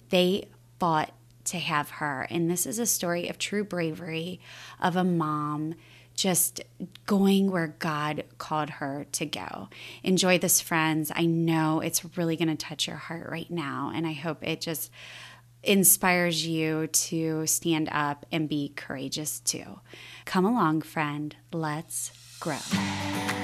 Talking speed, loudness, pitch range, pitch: 145 wpm, -27 LUFS, 150-170 Hz, 160 Hz